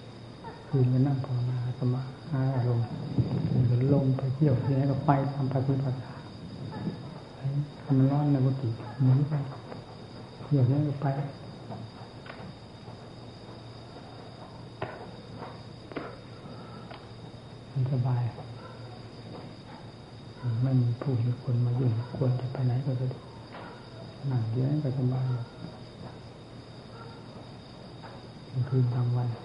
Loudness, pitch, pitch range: -29 LUFS, 130 Hz, 125-135 Hz